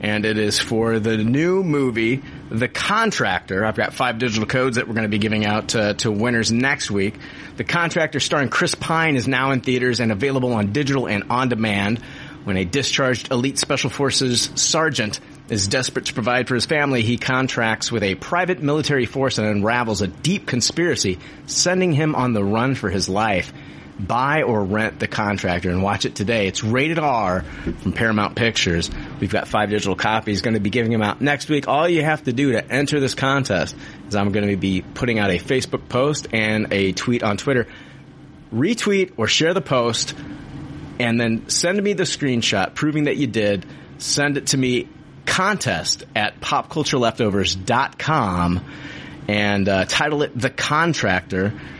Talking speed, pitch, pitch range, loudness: 180 wpm, 120 Hz, 105-140 Hz, -20 LUFS